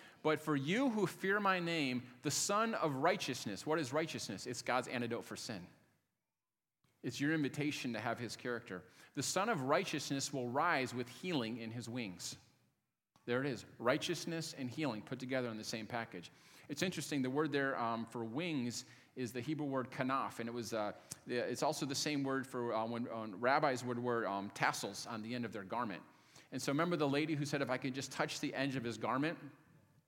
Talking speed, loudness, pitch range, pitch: 205 wpm, -39 LUFS, 120-150 Hz, 130 Hz